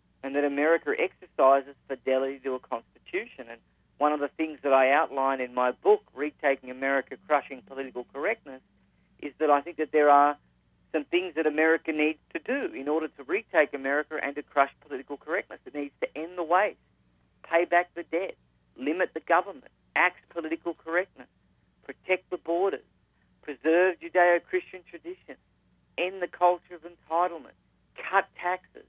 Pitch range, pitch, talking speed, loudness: 135-170 Hz, 150 Hz, 160 wpm, -27 LUFS